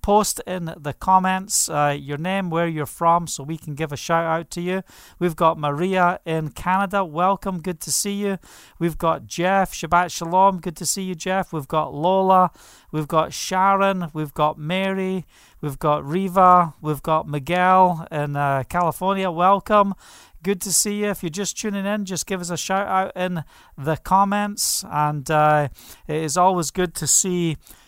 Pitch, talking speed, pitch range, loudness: 175 Hz, 180 wpm, 155-190 Hz, -21 LUFS